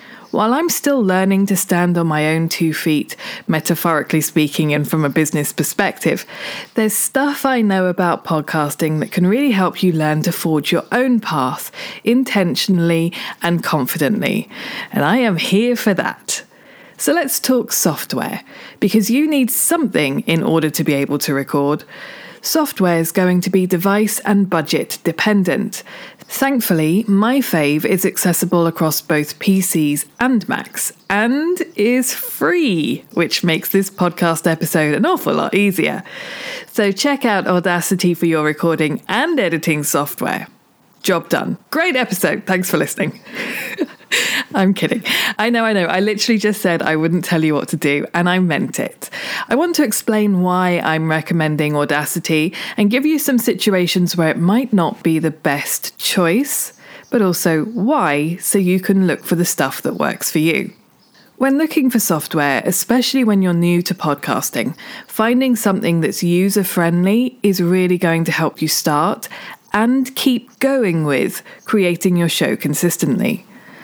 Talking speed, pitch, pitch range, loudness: 155 wpm, 185 Hz, 165-225 Hz, -16 LUFS